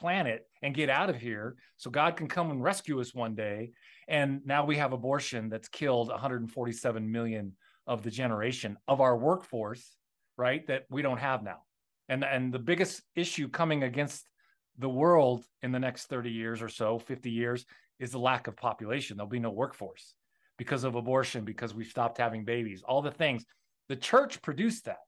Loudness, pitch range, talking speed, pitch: -32 LUFS, 115-145 Hz, 185 wpm, 125 Hz